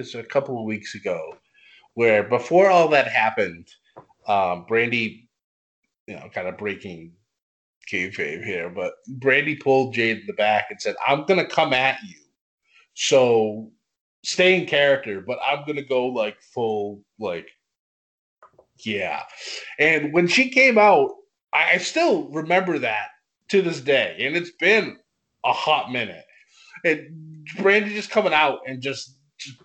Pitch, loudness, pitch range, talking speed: 145 Hz, -21 LUFS, 120-190 Hz, 150 wpm